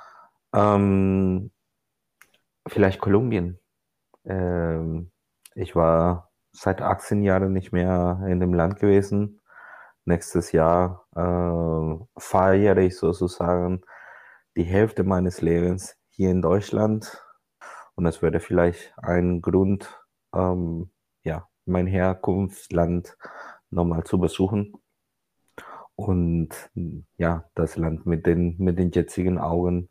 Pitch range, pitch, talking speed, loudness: 85-95 Hz, 90 Hz, 100 wpm, -23 LUFS